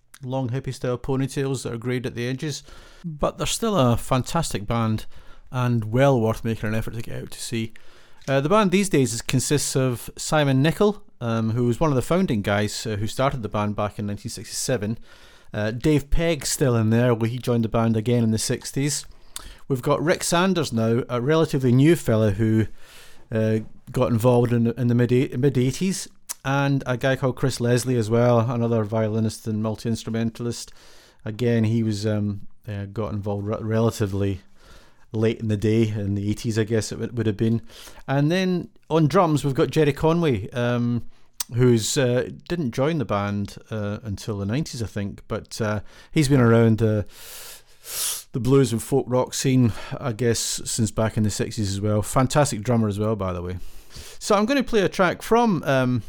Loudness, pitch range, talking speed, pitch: -23 LUFS, 110-135 Hz, 190 wpm, 120 Hz